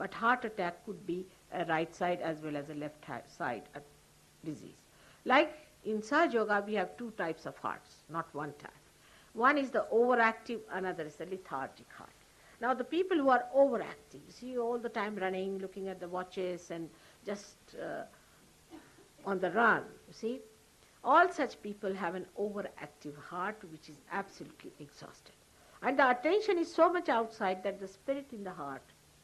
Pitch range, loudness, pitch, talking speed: 175-245 Hz, -34 LUFS, 200 Hz, 180 wpm